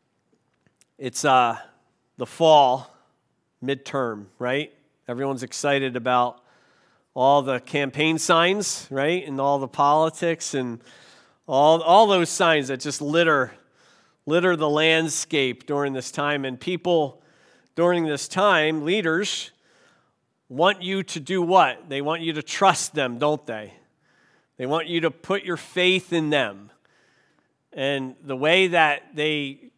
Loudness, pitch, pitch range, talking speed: -22 LUFS, 150 Hz, 135-170 Hz, 130 wpm